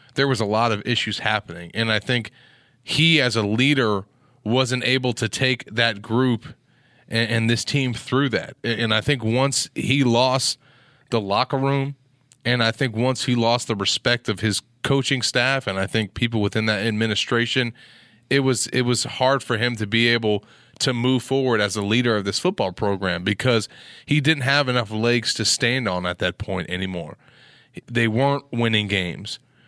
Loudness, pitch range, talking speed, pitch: -21 LUFS, 110-130 Hz, 185 wpm, 120 Hz